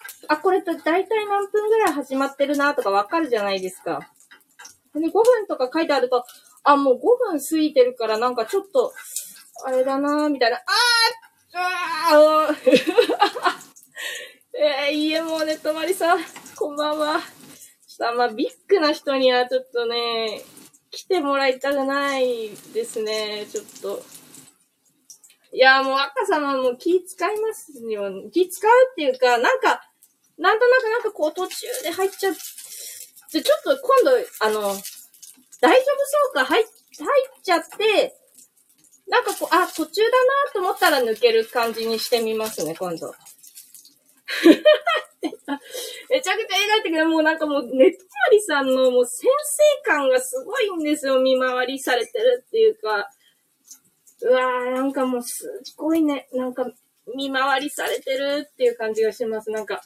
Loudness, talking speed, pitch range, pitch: -21 LUFS, 305 characters per minute, 260-410 Hz, 305 Hz